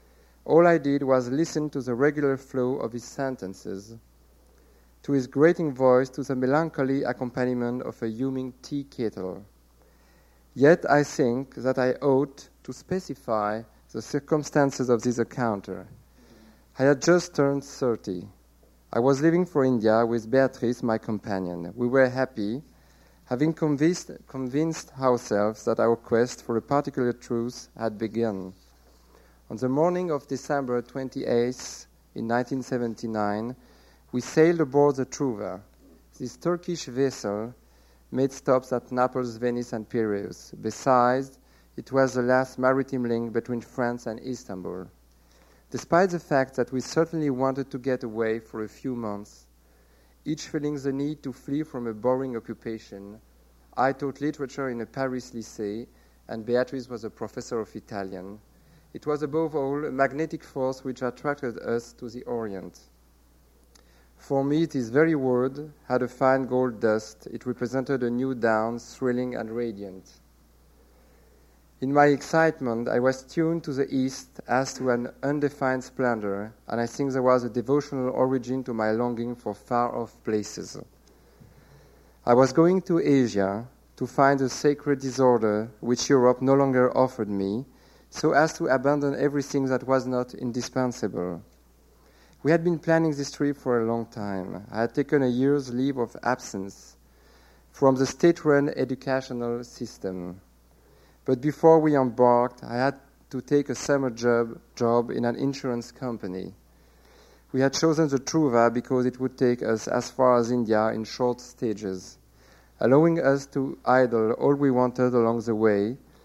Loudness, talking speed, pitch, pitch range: -26 LUFS, 150 wpm, 125 Hz, 110-135 Hz